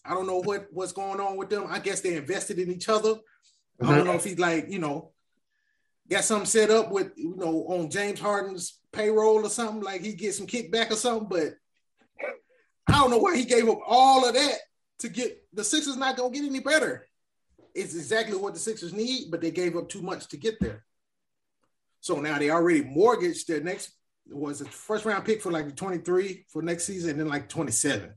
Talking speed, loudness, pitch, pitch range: 225 wpm, -26 LUFS, 200 Hz, 180-235 Hz